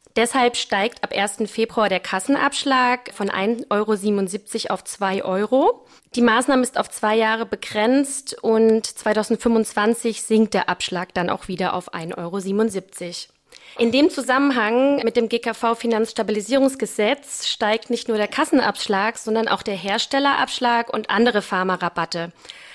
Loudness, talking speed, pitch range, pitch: -20 LUFS, 130 wpm, 200-240 Hz, 225 Hz